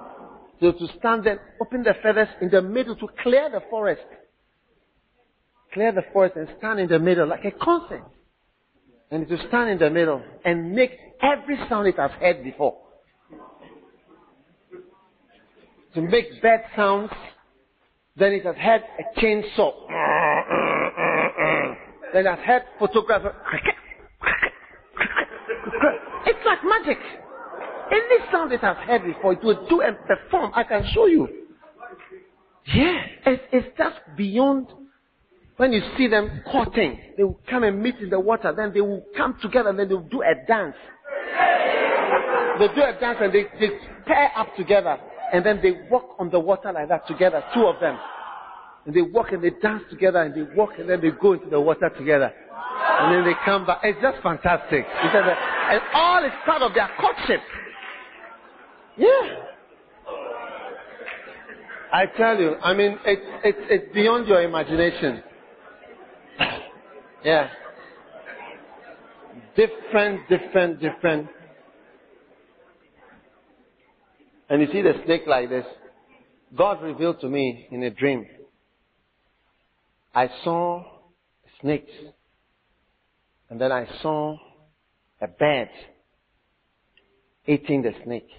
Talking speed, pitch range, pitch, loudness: 140 wpm, 175-255 Hz, 205 Hz, -22 LUFS